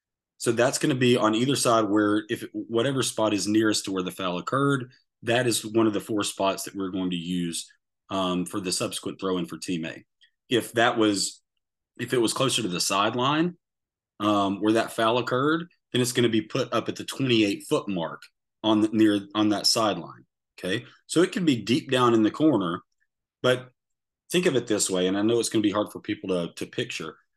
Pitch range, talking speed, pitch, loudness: 95-120 Hz, 225 wpm, 110 Hz, -25 LUFS